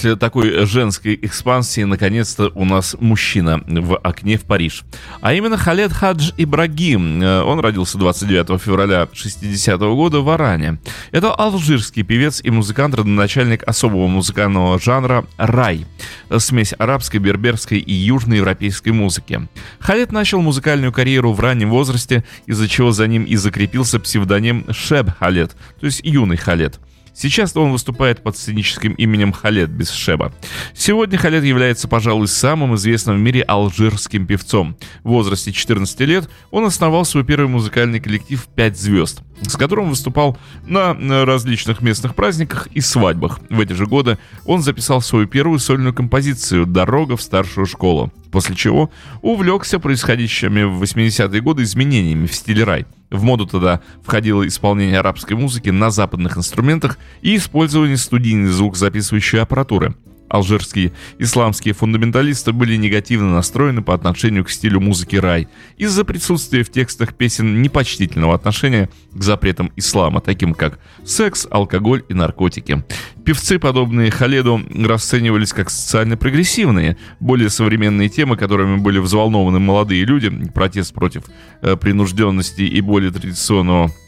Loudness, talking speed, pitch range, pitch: -15 LUFS, 135 wpm, 95-130 Hz, 110 Hz